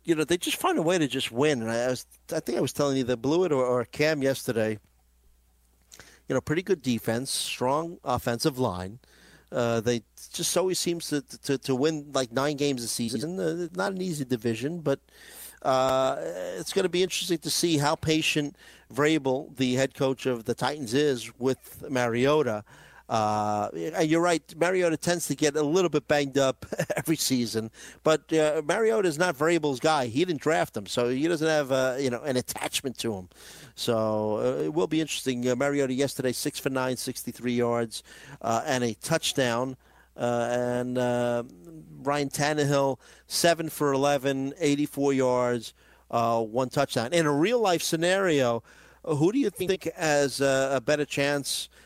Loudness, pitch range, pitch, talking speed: -27 LUFS, 120-155 Hz, 135 Hz, 180 wpm